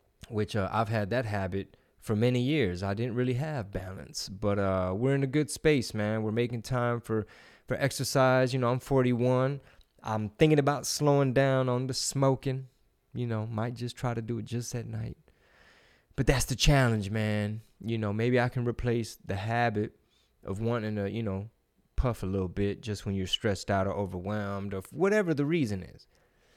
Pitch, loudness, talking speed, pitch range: 115 Hz, -30 LUFS, 190 wpm, 105-130 Hz